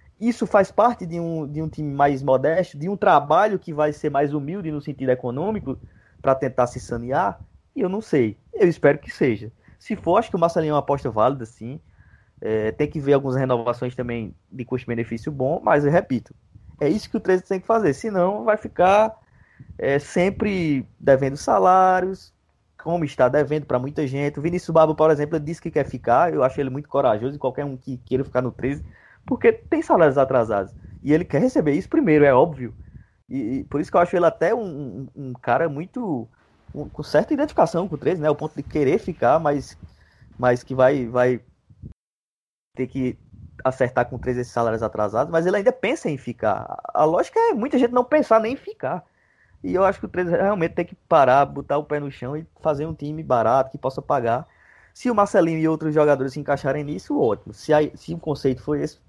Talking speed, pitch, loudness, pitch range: 210 wpm, 145 Hz, -21 LUFS, 125-170 Hz